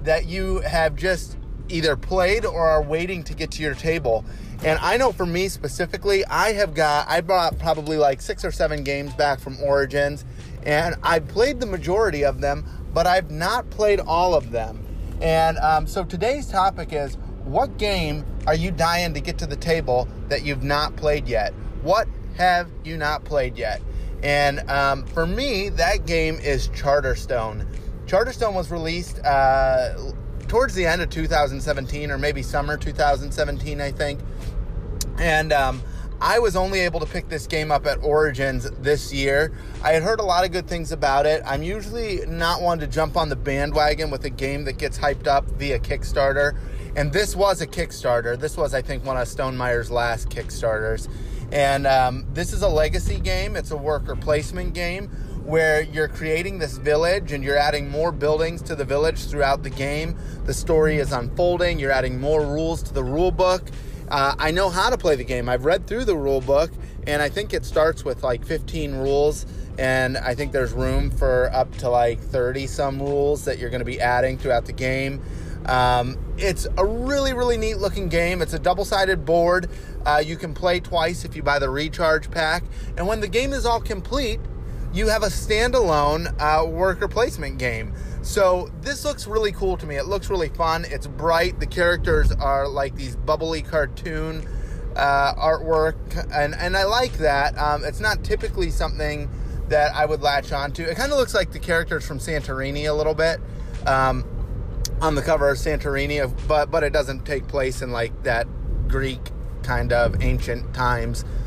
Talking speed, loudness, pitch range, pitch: 185 wpm, -22 LUFS, 135-165 Hz, 150 Hz